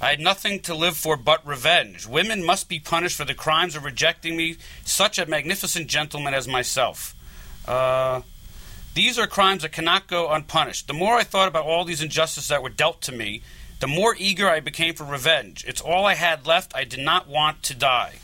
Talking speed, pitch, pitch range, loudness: 205 wpm, 155 Hz, 140-175 Hz, -22 LUFS